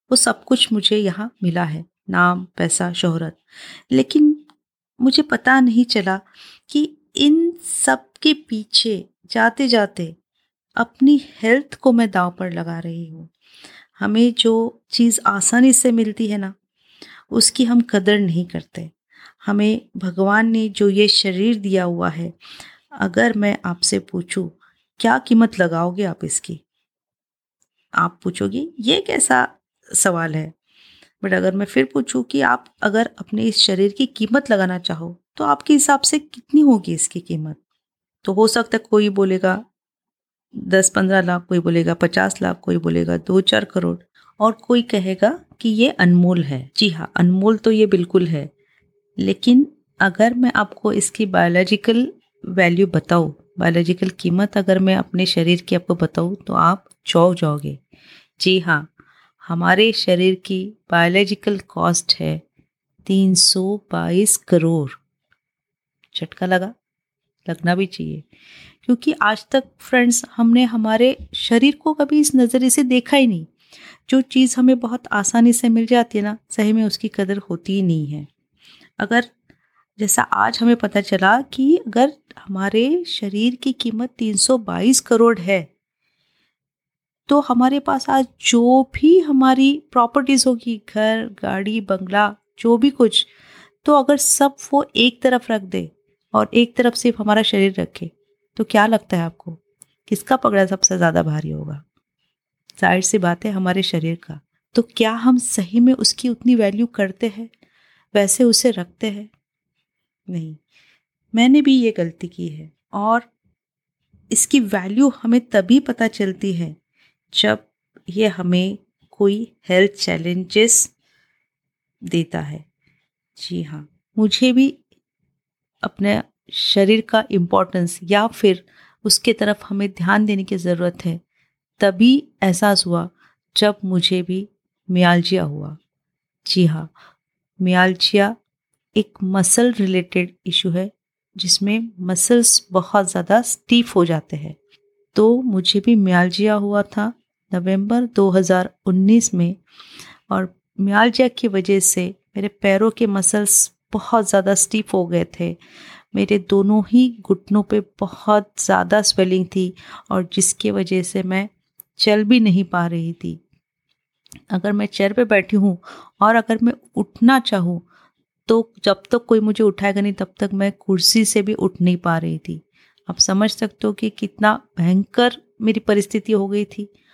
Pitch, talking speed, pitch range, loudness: 200 Hz, 145 wpm, 180-230 Hz, -17 LUFS